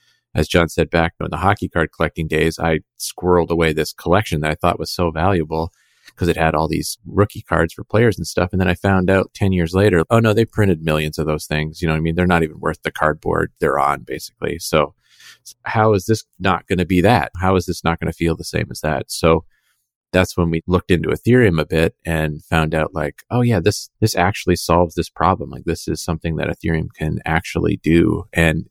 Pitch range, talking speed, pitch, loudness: 80-95 Hz, 230 wpm, 85 Hz, -18 LUFS